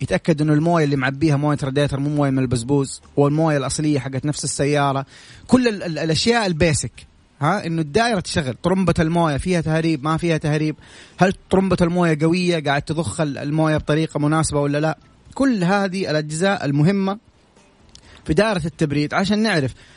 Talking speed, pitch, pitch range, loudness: 155 wpm, 155 Hz, 145-175 Hz, -19 LUFS